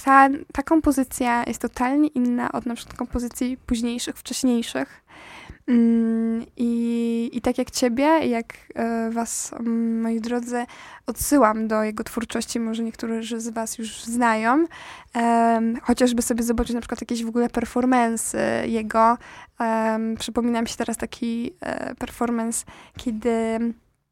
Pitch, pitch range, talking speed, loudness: 235 Hz, 230-245 Hz, 120 wpm, -23 LUFS